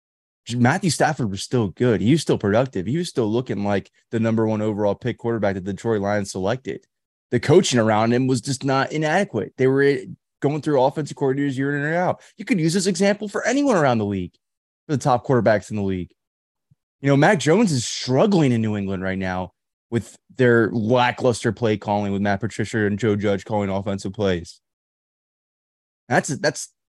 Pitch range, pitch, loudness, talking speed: 100-140 Hz, 120 Hz, -21 LUFS, 195 wpm